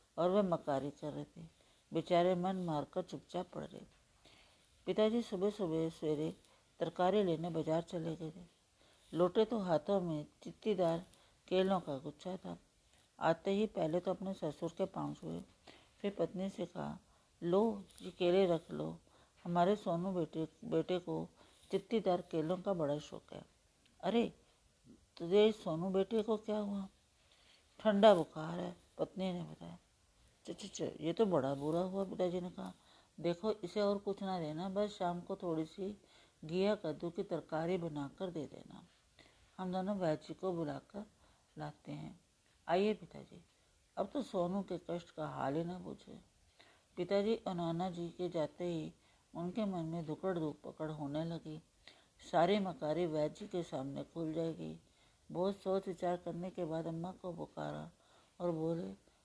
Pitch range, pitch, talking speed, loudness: 160-190 Hz, 175 Hz, 160 wpm, -38 LUFS